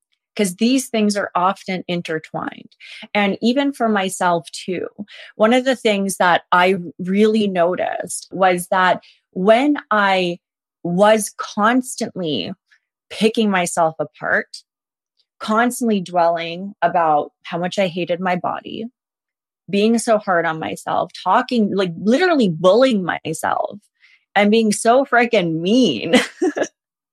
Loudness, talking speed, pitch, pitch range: -18 LUFS, 115 wpm, 205 Hz, 180-230 Hz